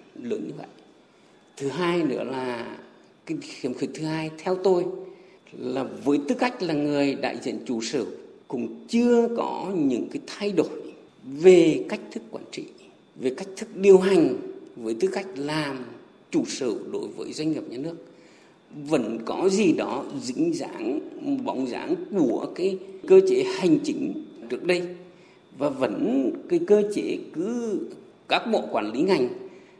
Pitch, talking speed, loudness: 240 Hz, 160 wpm, -25 LUFS